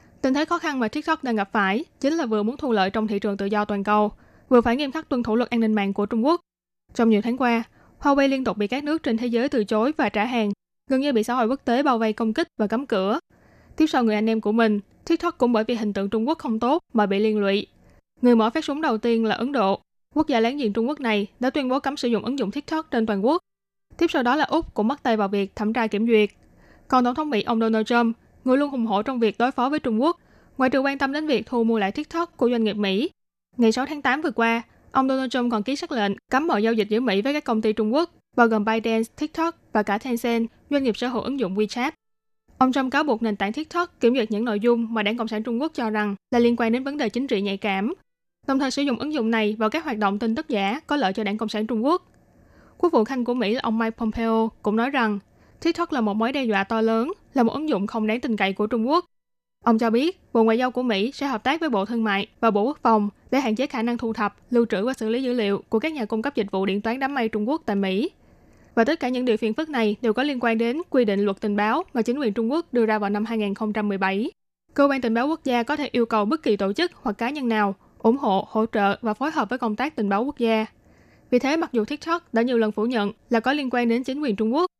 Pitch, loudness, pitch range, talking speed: 235 Hz, -23 LUFS, 215-270 Hz, 290 wpm